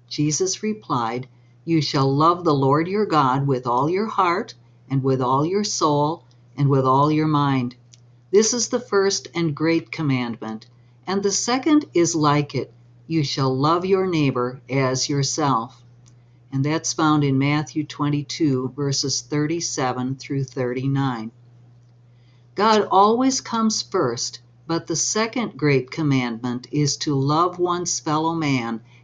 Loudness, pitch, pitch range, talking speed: -21 LUFS, 140 Hz, 125-165 Hz, 140 wpm